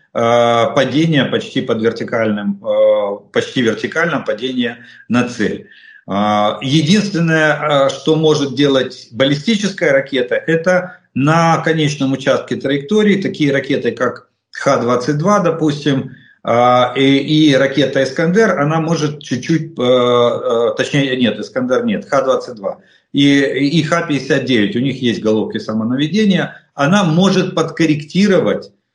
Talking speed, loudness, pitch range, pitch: 100 wpm, -15 LUFS, 125-160 Hz, 140 Hz